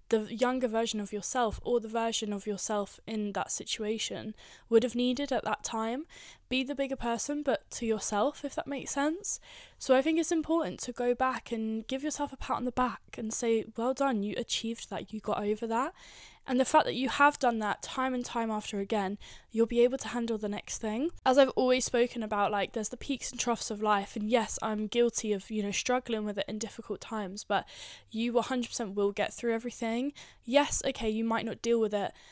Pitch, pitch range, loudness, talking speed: 230 Hz, 215-260 Hz, -31 LUFS, 220 wpm